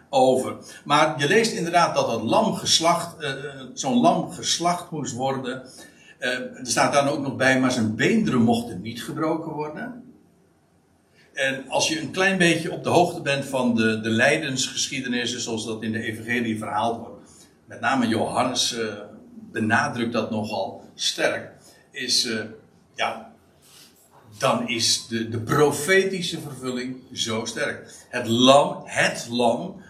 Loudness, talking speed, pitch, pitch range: -23 LUFS, 145 wpm, 130 Hz, 115-155 Hz